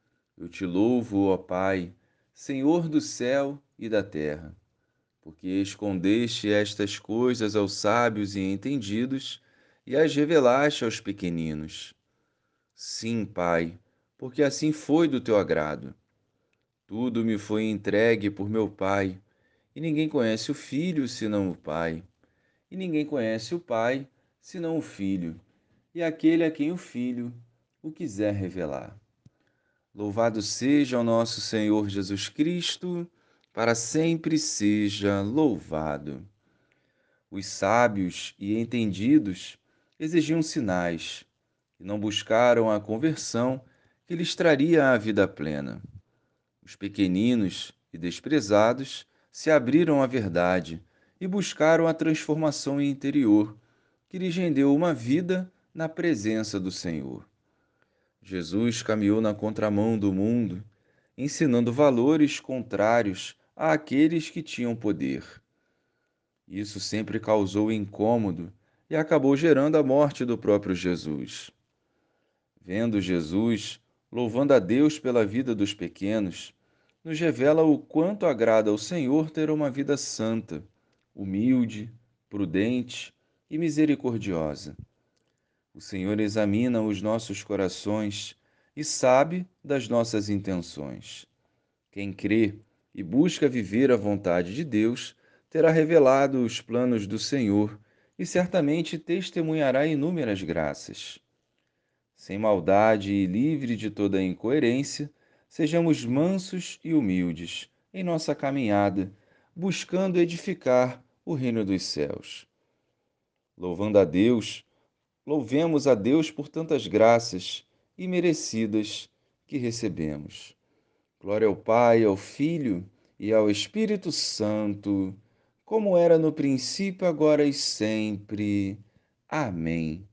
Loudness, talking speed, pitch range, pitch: -26 LUFS, 115 wpm, 100-150 Hz, 115 Hz